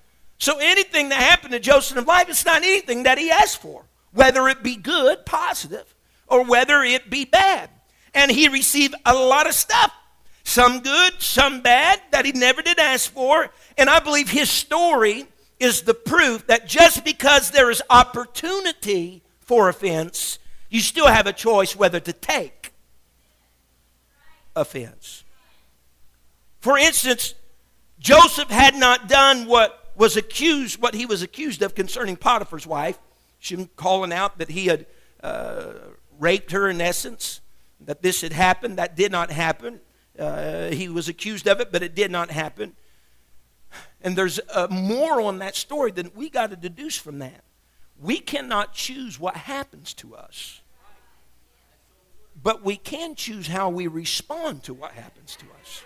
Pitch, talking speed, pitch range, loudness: 235 Hz, 160 wpm, 175-285 Hz, -18 LUFS